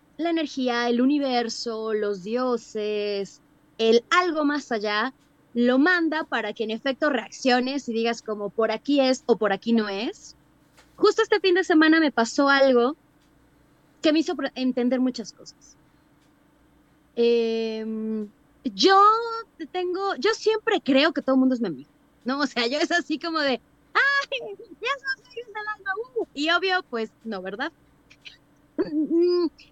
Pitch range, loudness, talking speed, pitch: 225-335 Hz, -23 LUFS, 150 wpm, 260 Hz